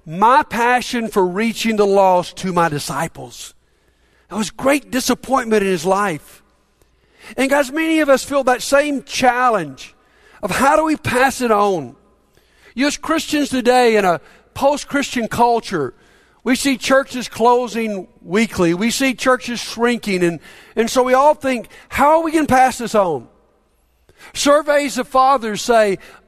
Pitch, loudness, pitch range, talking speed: 245 Hz, -16 LUFS, 205-270 Hz, 155 wpm